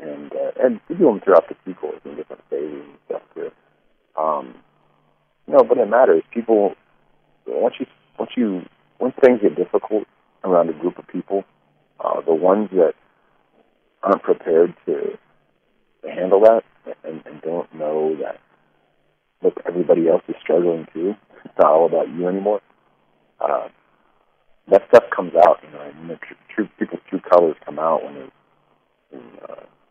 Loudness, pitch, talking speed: -19 LUFS, 110 Hz, 165 wpm